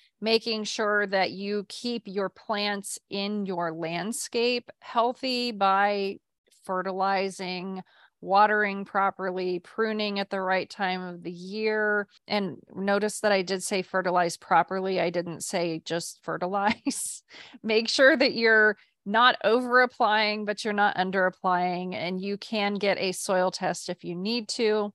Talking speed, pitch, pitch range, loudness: 140 wpm, 200 Hz, 185-215 Hz, -26 LUFS